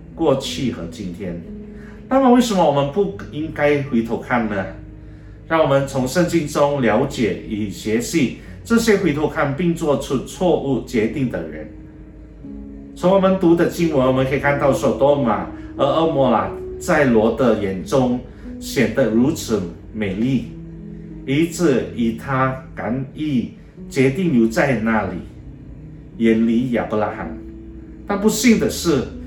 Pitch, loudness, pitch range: 135 Hz, -19 LUFS, 110-170 Hz